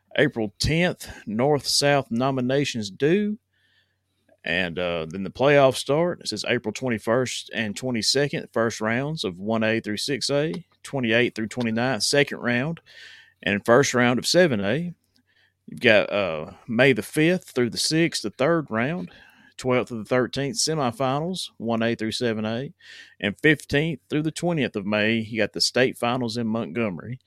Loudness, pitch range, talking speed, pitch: -23 LUFS, 115-150 Hz, 150 wpm, 125 Hz